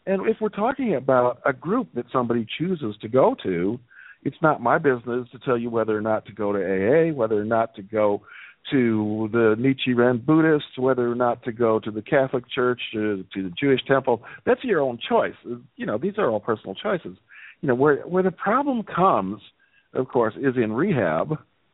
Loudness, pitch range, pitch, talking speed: -23 LUFS, 110-140 Hz, 125 Hz, 200 wpm